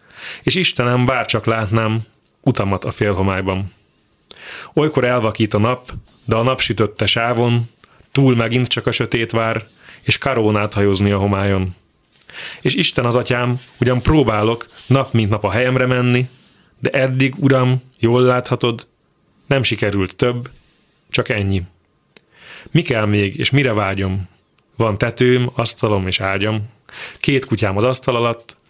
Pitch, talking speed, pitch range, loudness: 115 Hz, 135 wpm, 105-125 Hz, -17 LUFS